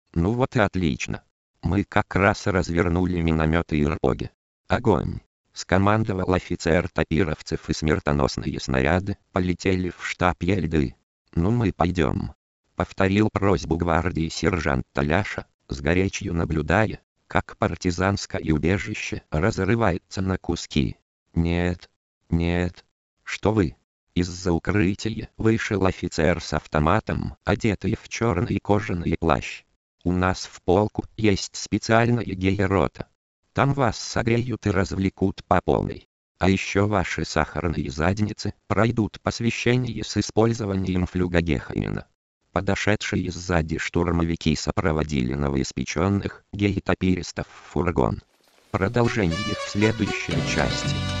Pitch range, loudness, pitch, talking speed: 80-105 Hz, -24 LUFS, 90 Hz, 105 wpm